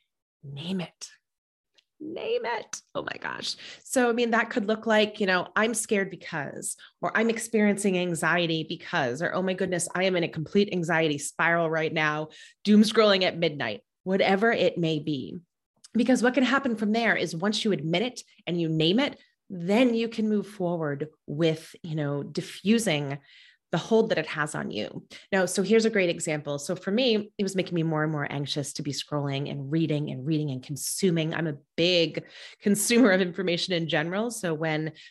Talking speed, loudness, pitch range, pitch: 190 wpm, -26 LUFS, 160-215 Hz, 180 Hz